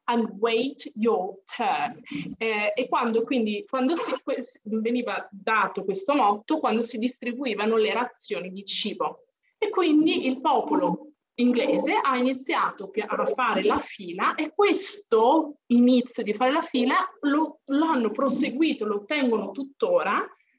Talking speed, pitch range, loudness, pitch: 135 wpm, 225-305 Hz, -25 LUFS, 255 Hz